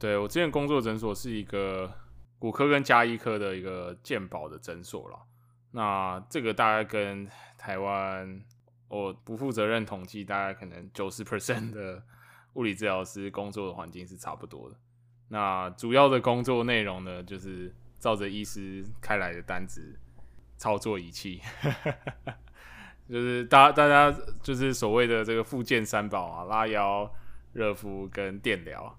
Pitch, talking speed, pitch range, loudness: 105 Hz, 245 characters per minute, 95-120 Hz, -28 LUFS